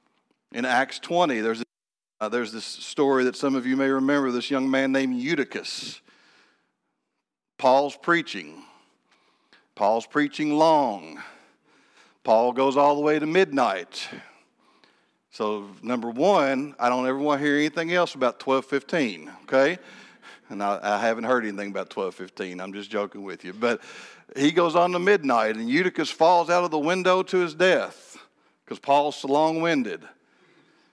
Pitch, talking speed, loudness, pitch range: 140 Hz, 155 wpm, -24 LUFS, 120-165 Hz